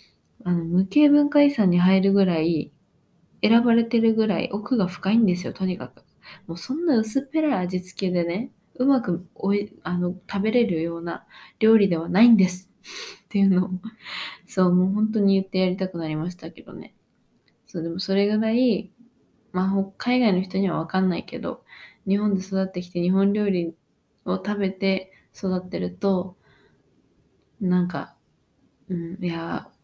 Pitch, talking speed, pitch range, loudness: 190 Hz, 310 characters per minute, 180-215 Hz, -23 LUFS